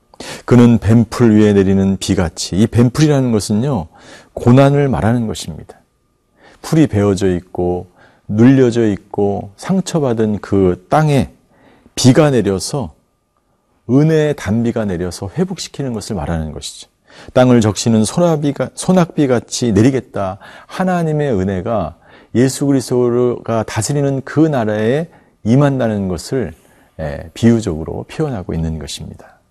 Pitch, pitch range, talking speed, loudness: 115 Hz, 100-140 Hz, 280 characters per minute, -15 LUFS